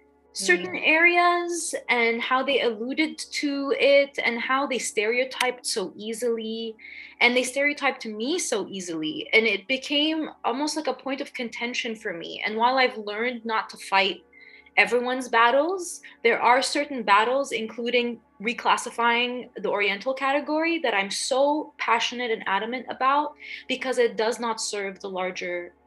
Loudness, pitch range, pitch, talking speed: -24 LUFS, 225-285 Hz, 245 Hz, 145 wpm